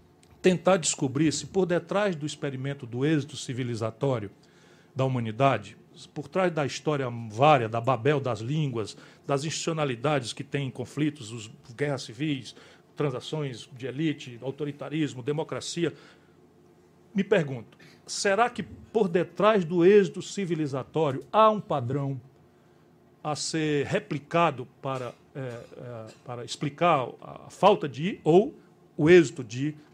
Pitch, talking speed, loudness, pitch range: 145 Hz, 120 wpm, -27 LUFS, 130-165 Hz